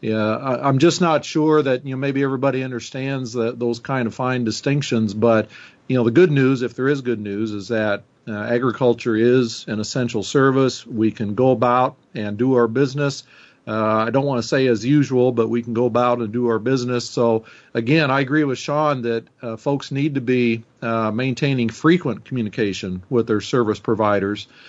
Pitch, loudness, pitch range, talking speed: 125 Hz, -20 LUFS, 115-135 Hz, 195 wpm